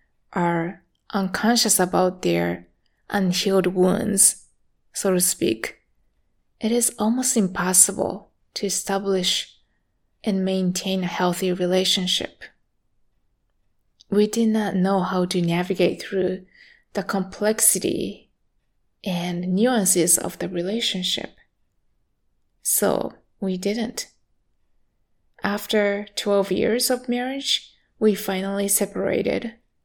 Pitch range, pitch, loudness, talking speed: 185-210 Hz, 195 Hz, -22 LUFS, 90 wpm